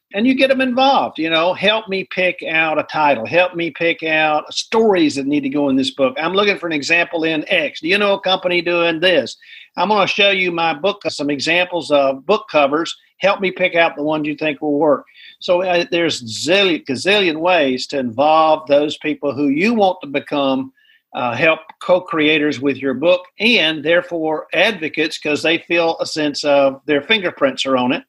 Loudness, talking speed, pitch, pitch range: -16 LUFS, 205 wpm, 165 Hz, 150-185 Hz